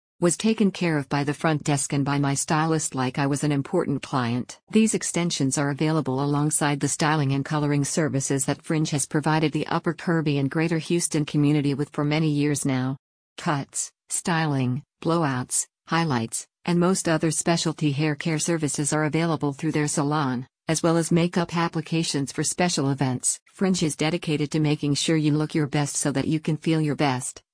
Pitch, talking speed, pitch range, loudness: 155 Hz, 185 wpm, 145-165 Hz, -24 LUFS